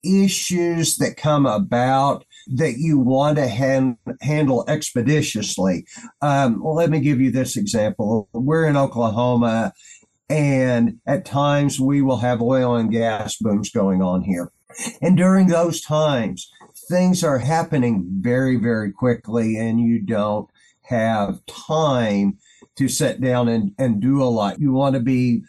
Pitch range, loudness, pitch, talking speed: 115-150 Hz, -19 LUFS, 130 Hz, 145 wpm